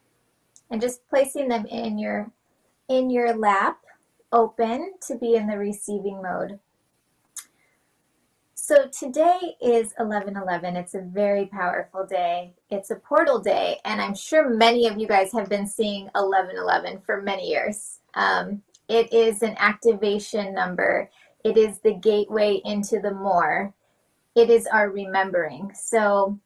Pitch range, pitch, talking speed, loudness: 200-235 Hz, 210 Hz, 145 wpm, -23 LUFS